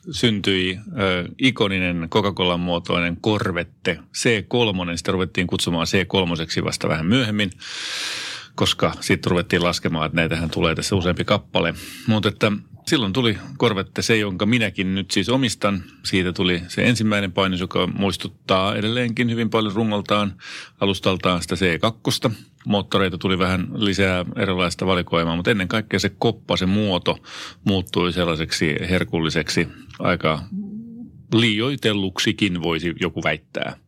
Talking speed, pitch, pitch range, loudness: 125 wpm, 95 Hz, 90-110 Hz, -21 LUFS